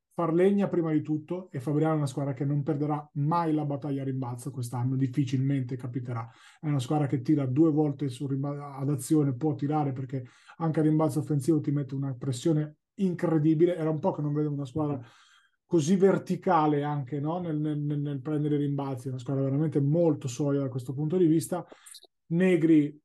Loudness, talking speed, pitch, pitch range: -28 LUFS, 190 wpm, 150 Hz, 140-160 Hz